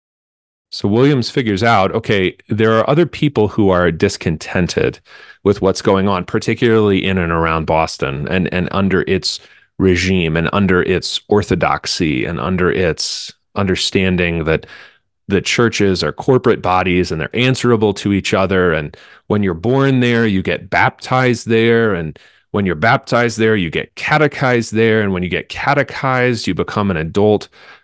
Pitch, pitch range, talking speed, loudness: 100 Hz, 90-115 Hz, 155 wpm, -15 LUFS